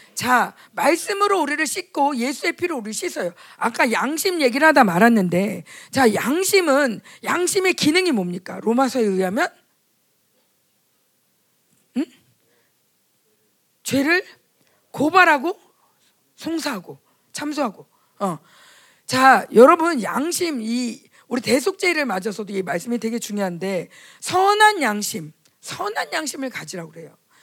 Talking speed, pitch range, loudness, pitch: 245 characters per minute, 215-335 Hz, -19 LUFS, 270 Hz